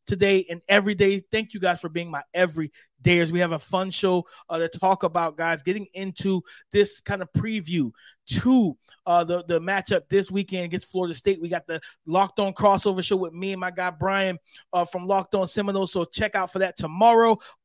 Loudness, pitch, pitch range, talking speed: -24 LUFS, 185 Hz, 175-195 Hz, 210 wpm